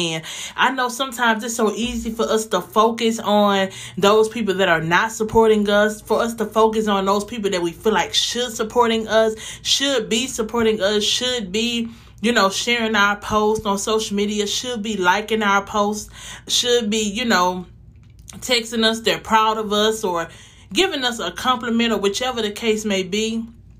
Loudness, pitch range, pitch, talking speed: -19 LUFS, 200-230 Hz, 220 Hz, 185 wpm